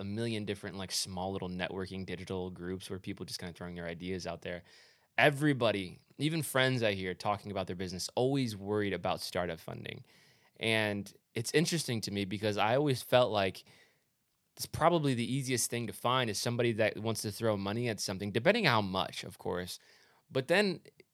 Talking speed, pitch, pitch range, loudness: 185 wpm, 105 Hz, 95-120 Hz, -33 LUFS